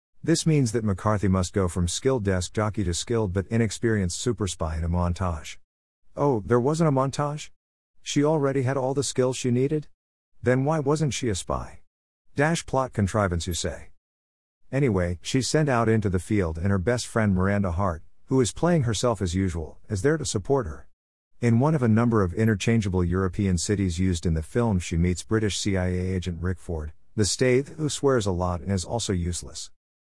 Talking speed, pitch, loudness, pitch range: 195 wpm, 100 Hz, -25 LUFS, 90-125 Hz